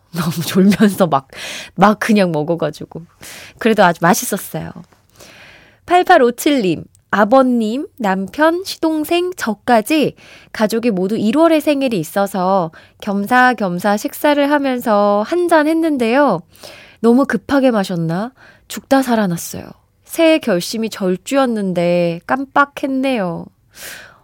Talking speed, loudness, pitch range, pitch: 235 characters per minute, -15 LUFS, 190-280 Hz, 220 Hz